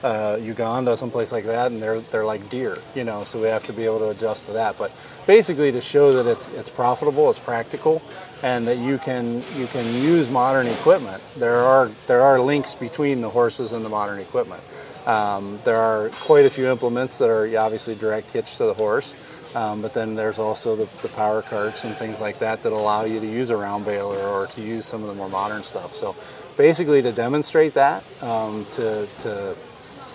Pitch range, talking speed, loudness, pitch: 110-130 Hz, 210 wpm, -21 LUFS, 115 Hz